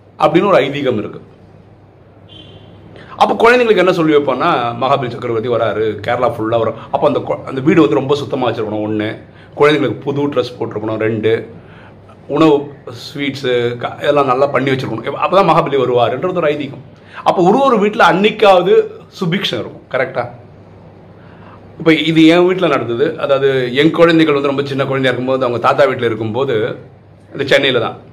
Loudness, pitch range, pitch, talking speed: -14 LUFS, 115-160 Hz, 135 Hz, 145 wpm